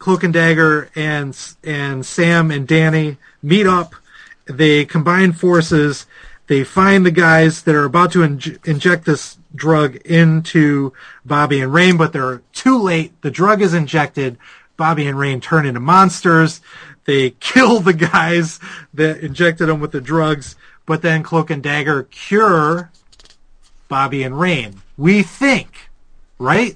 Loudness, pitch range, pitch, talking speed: -14 LUFS, 145-175 Hz, 160 Hz, 145 wpm